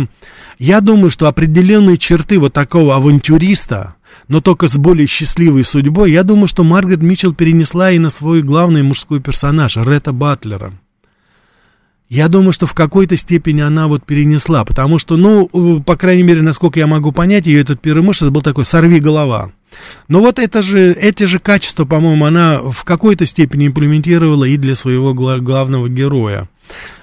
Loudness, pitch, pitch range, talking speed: -10 LUFS, 160 Hz, 145-175 Hz, 160 wpm